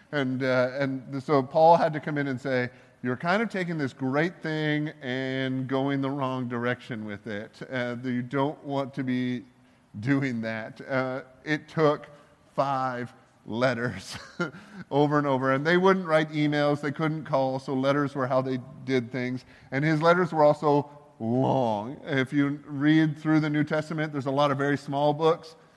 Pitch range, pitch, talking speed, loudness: 130-150 Hz, 140 Hz, 175 wpm, -27 LUFS